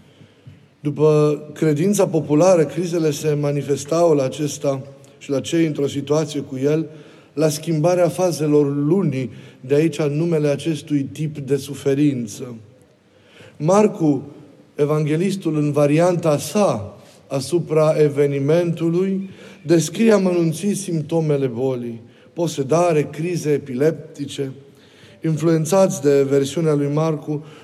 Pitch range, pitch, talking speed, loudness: 140-165 Hz, 150 Hz, 100 wpm, -19 LUFS